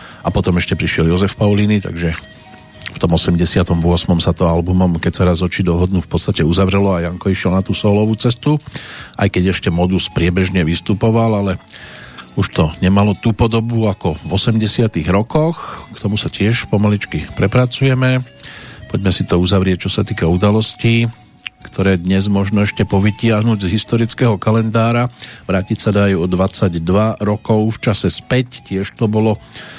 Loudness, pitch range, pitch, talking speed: -15 LUFS, 90-115 Hz, 100 Hz, 155 wpm